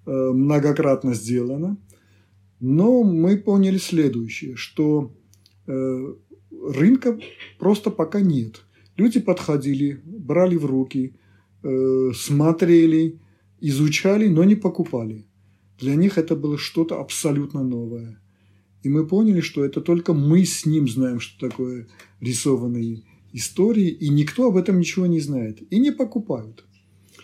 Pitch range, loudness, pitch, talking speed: 120-175 Hz, -21 LUFS, 145 Hz, 115 wpm